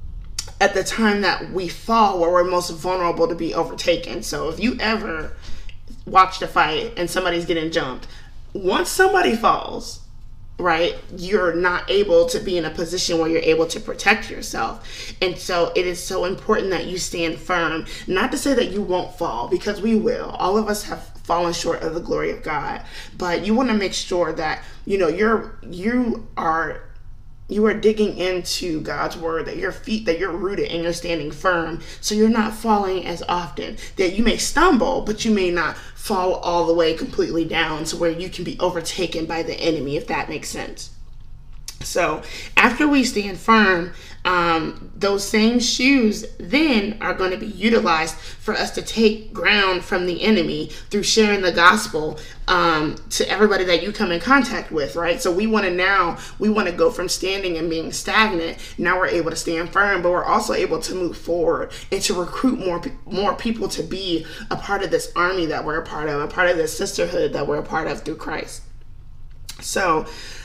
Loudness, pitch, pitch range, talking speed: -20 LUFS, 185 Hz, 170-215 Hz, 195 wpm